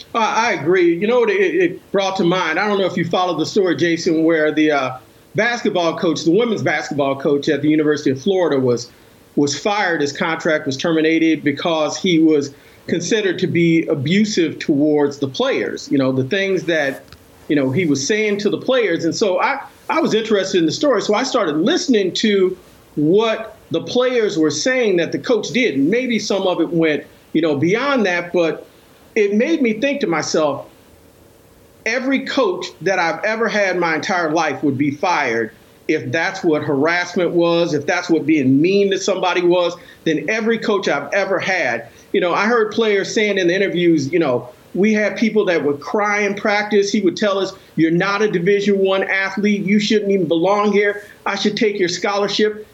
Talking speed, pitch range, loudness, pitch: 195 wpm, 155-210 Hz, -17 LUFS, 185 Hz